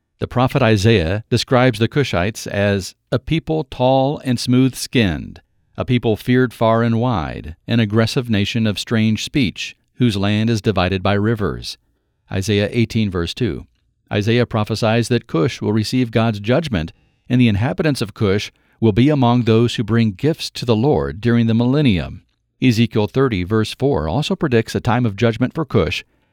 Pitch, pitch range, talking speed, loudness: 115 Hz, 105-125 Hz, 165 wpm, -18 LUFS